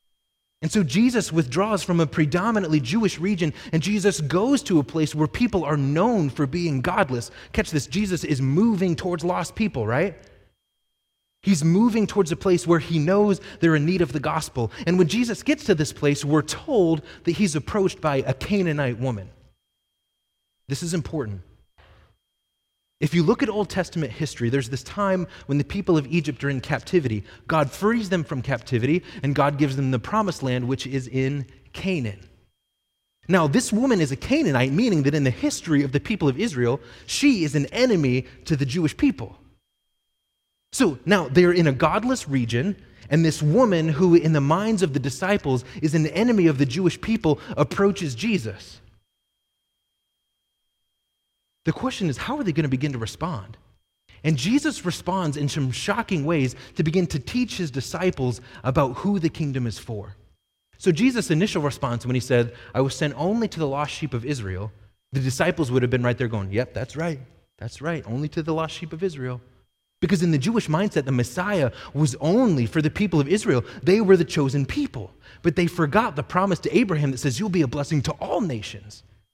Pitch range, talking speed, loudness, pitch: 130-185 Hz, 190 wpm, -23 LUFS, 155 Hz